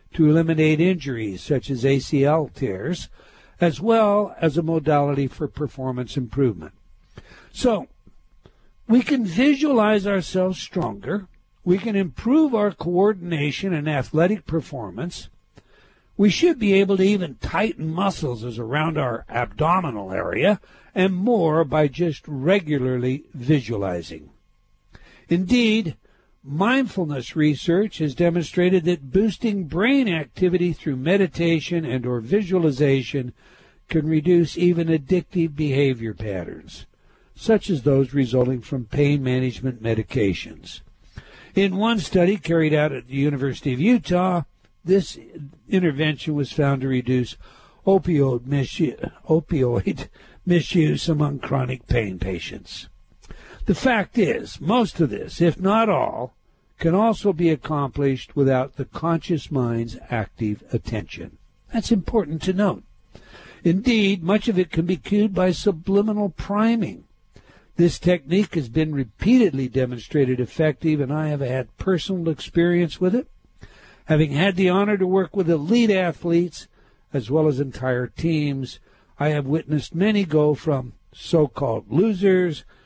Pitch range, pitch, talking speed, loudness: 135-190 Hz, 160 Hz, 125 wpm, -22 LUFS